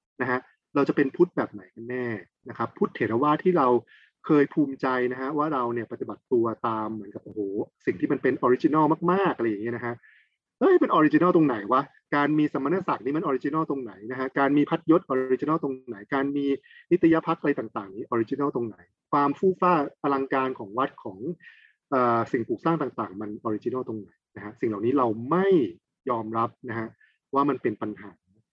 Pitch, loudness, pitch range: 135 Hz, -26 LUFS, 115-150 Hz